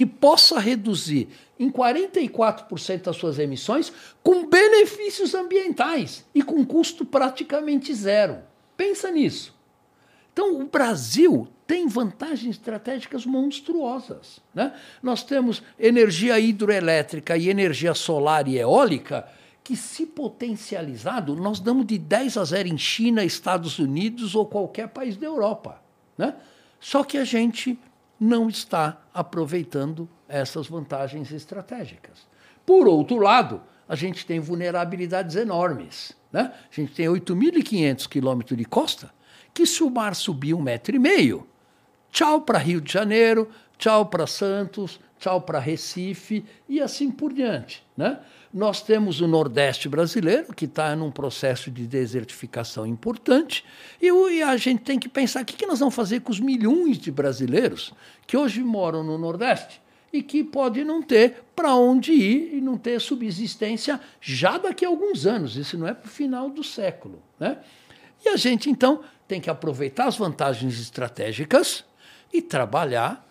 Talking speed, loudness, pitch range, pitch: 145 wpm, -23 LUFS, 165-275 Hz, 225 Hz